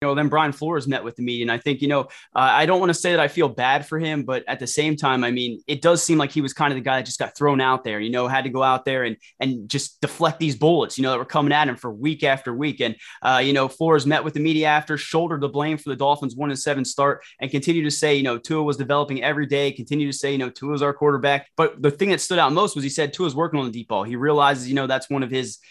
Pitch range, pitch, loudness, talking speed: 130-150 Hz, 145 Hz, -21 LUFS, 320 wpm